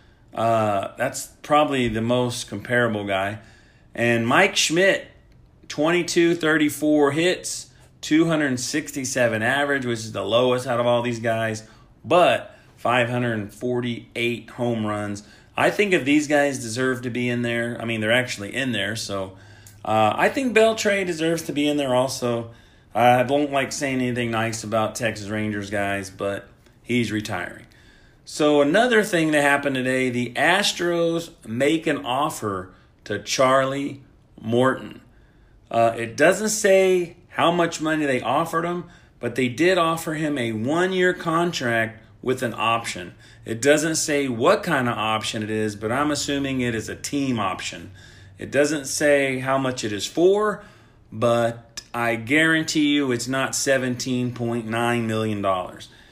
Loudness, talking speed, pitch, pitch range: -22 LUFS, 145 wpm, 125 Hz, 115-145 Hz